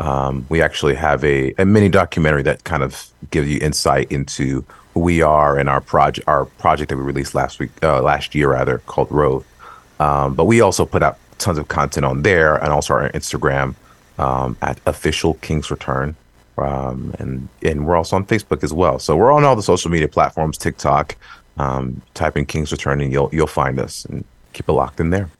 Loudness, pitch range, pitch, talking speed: -17 LUFS, 70-80 Hz, 75 Hz, 210 wpm